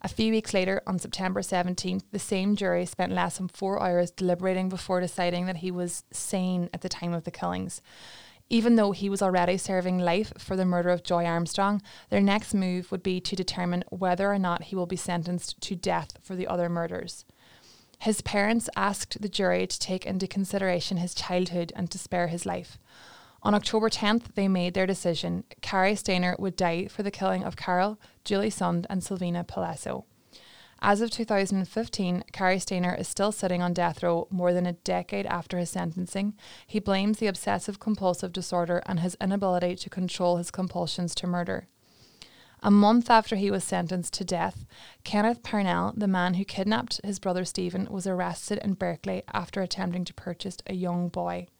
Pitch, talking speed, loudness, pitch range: 185 Hz, 185 wpm, -28 LUFS, 175-195 Hz